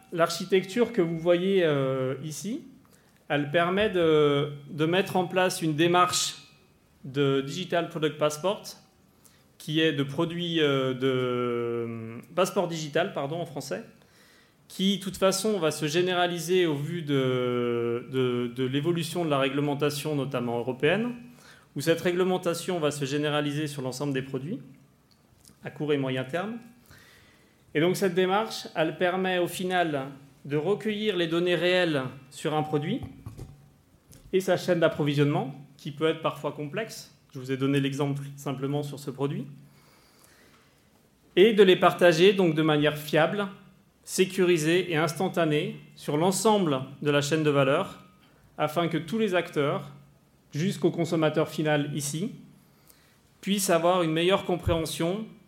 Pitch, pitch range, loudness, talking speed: 160 Hz, 145-180 Hz, -26 LUFS, 140 wpm